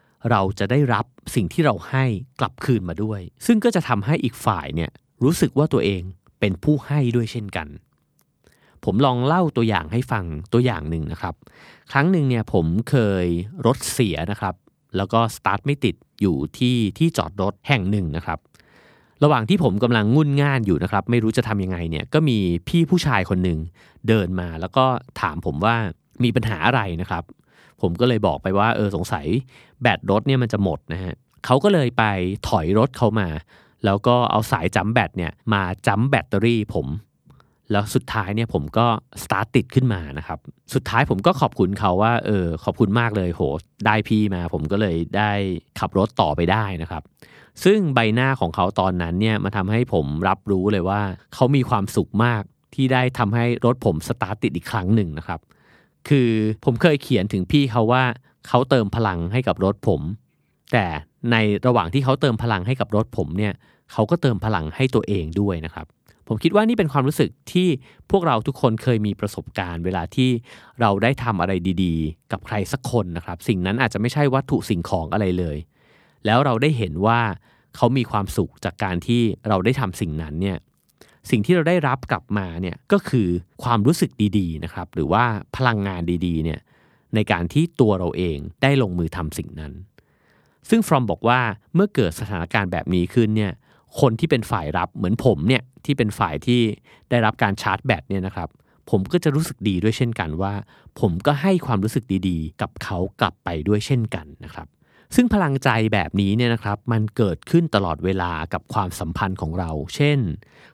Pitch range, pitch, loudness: 95-125 Hz, 110 Hz, -21 LUFS